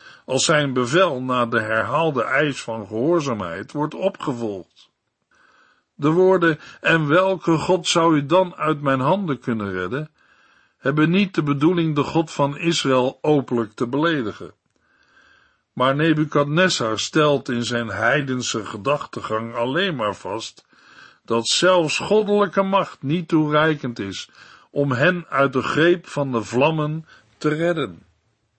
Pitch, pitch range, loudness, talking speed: 145 Hz, 120-165 Hz, -20 LUFS, 130 wpm